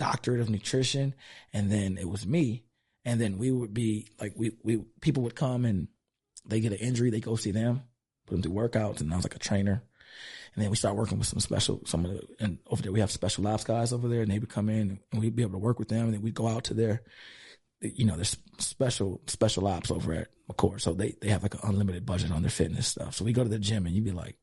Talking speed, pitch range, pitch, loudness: 270 wpm, 100-120 Hz, 110 Hz, -30 LUFS